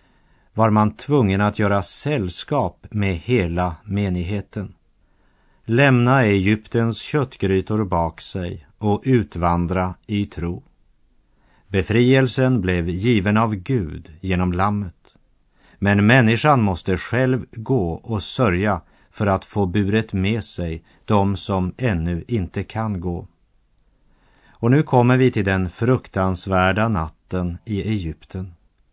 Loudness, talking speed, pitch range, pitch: -20 LUFS, 110 wpm, 90-115 Hz, 100 Hz